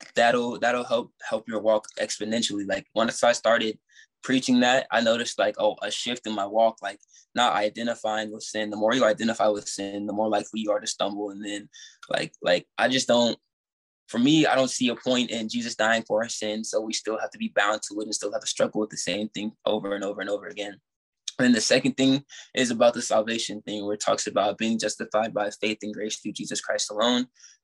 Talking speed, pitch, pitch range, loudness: 235 wpm, 110 Hz, 105-120 Hz, -25 LUFS